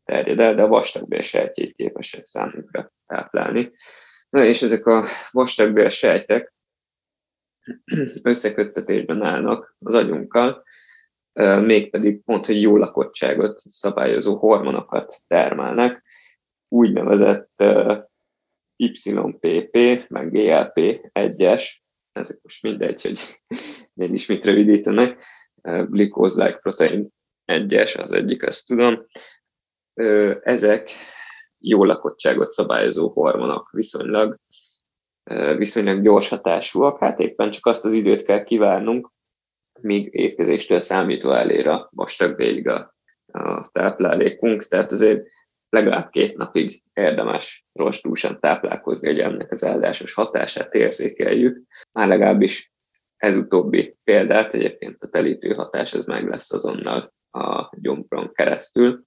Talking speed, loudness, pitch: 105 wpm, -19 LUFS, 120 Hz